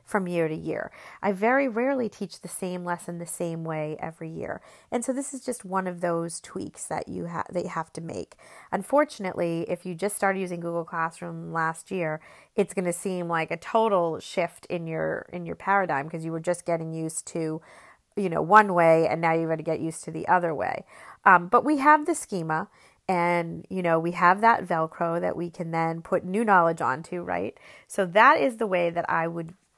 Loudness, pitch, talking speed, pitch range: -26 LUFS, 175 Hz, 220 wpm, 165-195 Hz